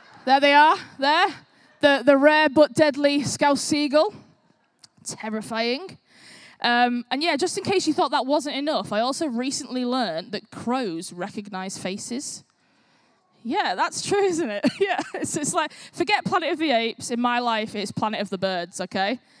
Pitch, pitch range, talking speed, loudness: 270 Hz, 220-305 Hz, 165 wpm, -23 LUFS